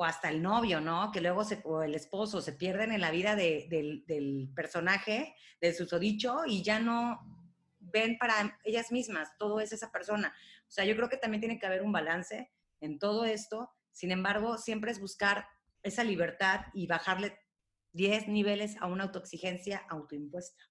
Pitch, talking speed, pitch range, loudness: 200 Hz, 180 wpm, 170-215 Hz, -33 LUFS